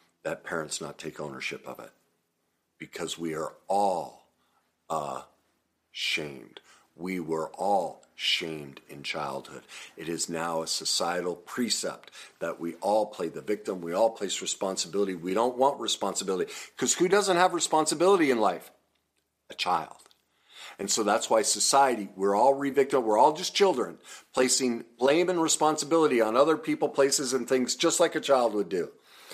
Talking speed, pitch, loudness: 155 wpm, 130 Hz, -27 LUFS